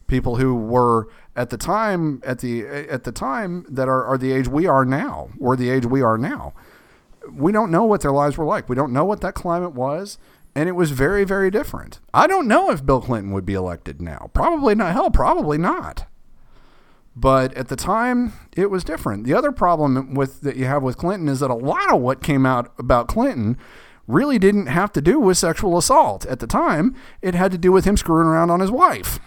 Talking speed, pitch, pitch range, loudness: 225 wpm, 145 Hz, 130-185 Hz, -19 LUFS